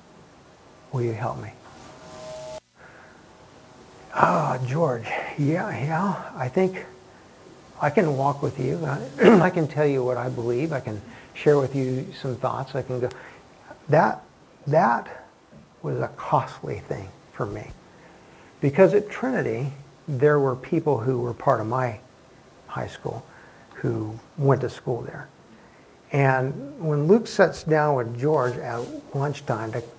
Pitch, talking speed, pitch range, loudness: 135 Hz, 140 wpm, 125-155 Hz, -24 LUFS